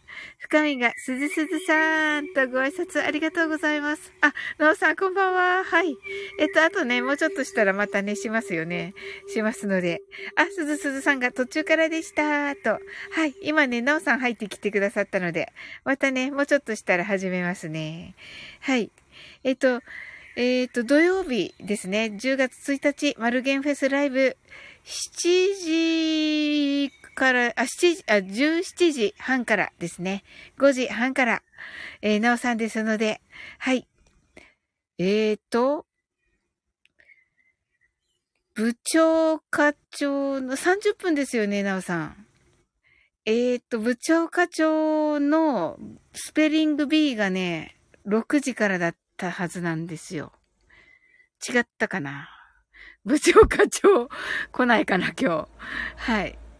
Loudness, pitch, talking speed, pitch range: -24 LUFS, 275 Hz, 245 characters per minute, 220-315 Hz